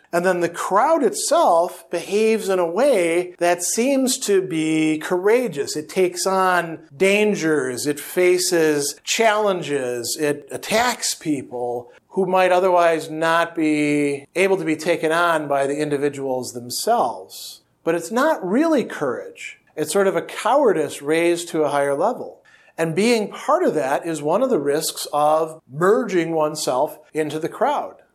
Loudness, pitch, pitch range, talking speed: -20 LUFS, 170 Hz, 150-195 Hz, 145 wpm